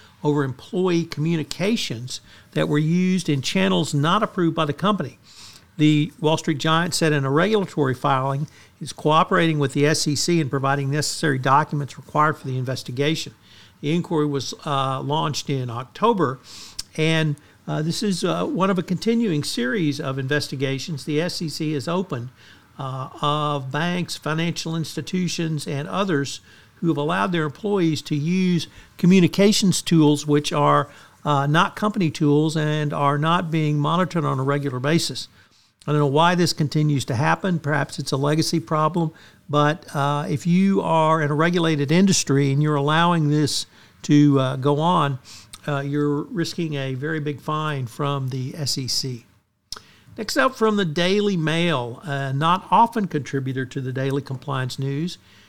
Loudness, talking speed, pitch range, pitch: -21 LUFS, 155 wpm, 140-165 Hz, 150 Hz